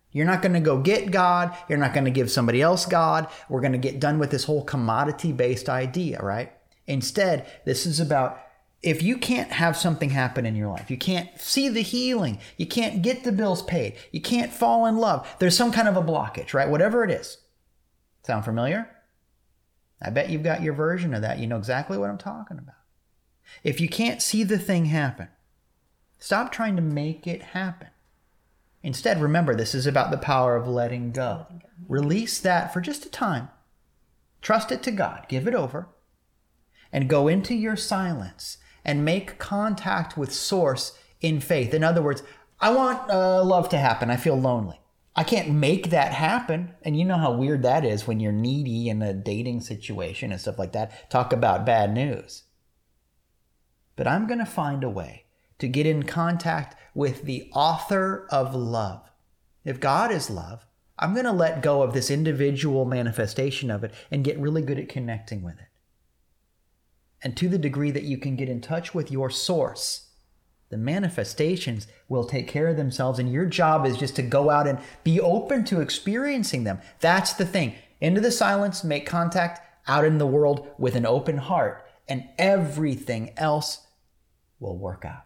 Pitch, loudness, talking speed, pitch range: 145 Hz, -24 LUFS, 185 wpm, 120-175 Hz